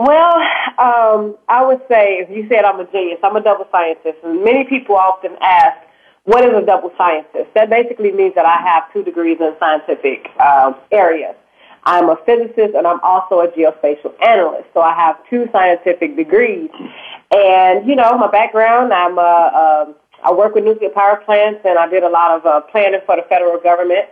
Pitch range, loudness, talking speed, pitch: 175-235 Hz, -13 LUFS, 195 wpm, 200 Hz